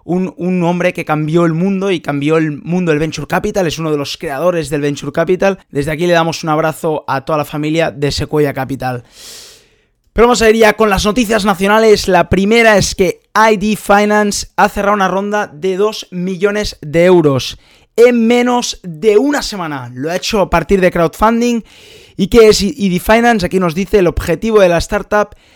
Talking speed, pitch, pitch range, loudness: 195 wpm, 185 Hz, 160-210 Hz, -13 LUFS